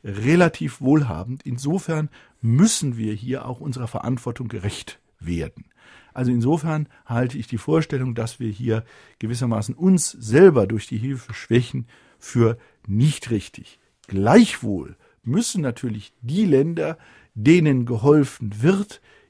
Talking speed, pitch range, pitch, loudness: 120 wpm, 115-150 Hz, 125 Hz, -21 LUFS